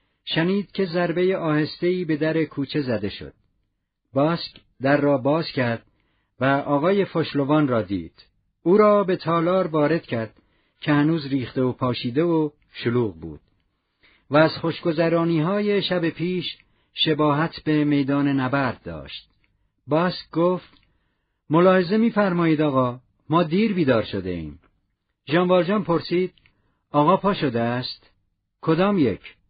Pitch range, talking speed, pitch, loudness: 115-170 Hz, 130 wpm, 150 Hz, -22 LUFS